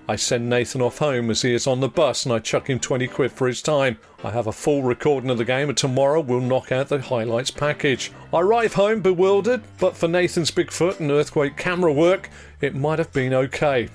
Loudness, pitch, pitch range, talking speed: -21 LUFS, 140 Hz, 125-160 Hz, 230 wpm